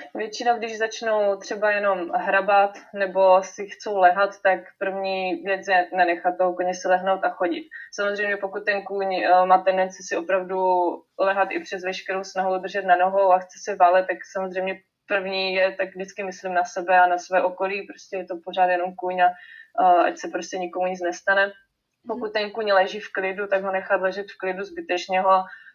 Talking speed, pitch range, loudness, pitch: 185 wpm, 185-200 Hz, -23 LUFS, 190 Hz